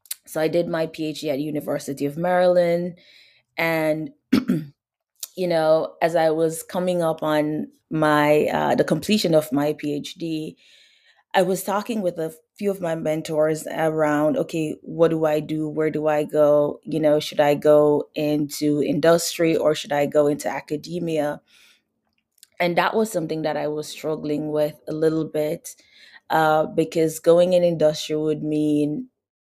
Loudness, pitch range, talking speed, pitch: -22 LUFS, 150-170 Hz, 155 wpm, 155 Hz